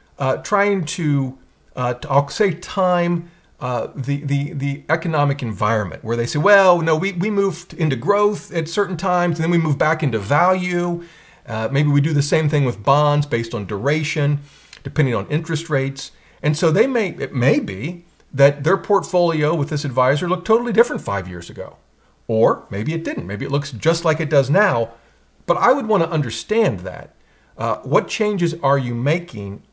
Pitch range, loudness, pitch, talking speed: 135-175 Hz, -19 LUFS, 150 Hz, 190 wpm